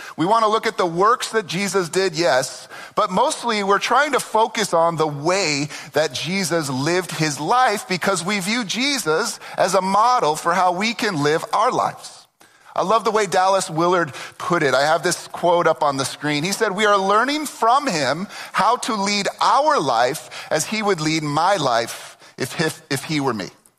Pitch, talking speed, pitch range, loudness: 185 Hz, 195 wpm, 155-220 Hz, -19 LUFS